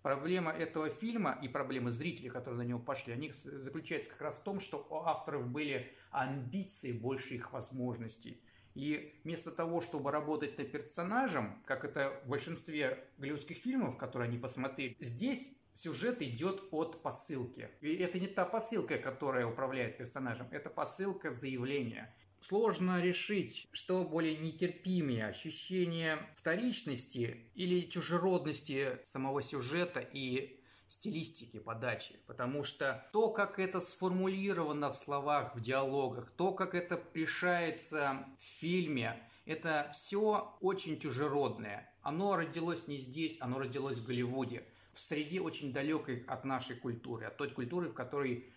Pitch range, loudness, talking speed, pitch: 130-175 Hz, -38 LUFS, 135 wpm, 145 Hz